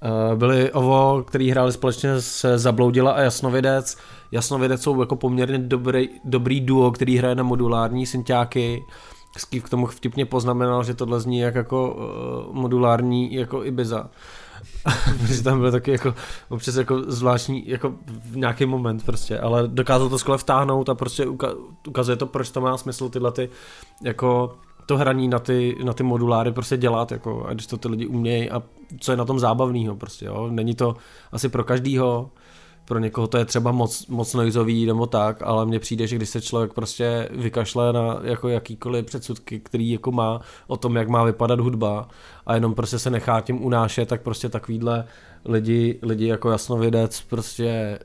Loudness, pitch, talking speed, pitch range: -22 LUFS, 120 Hz, 175 wpm, 115-130 Hz